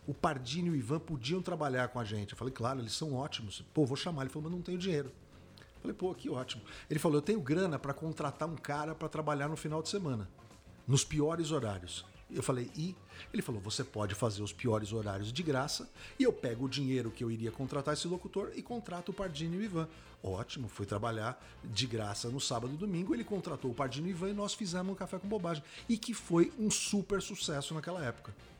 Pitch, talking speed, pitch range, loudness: 145 Hz, 230 wpm, 120-175 Hz, -37 LUFS